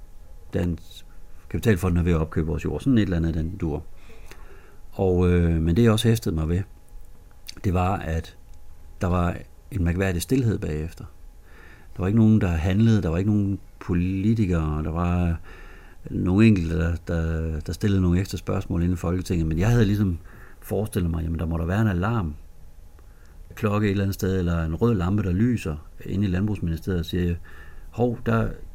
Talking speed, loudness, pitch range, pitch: 190 wpm, -24 LUFS, 80-100 Hz, 90 Hz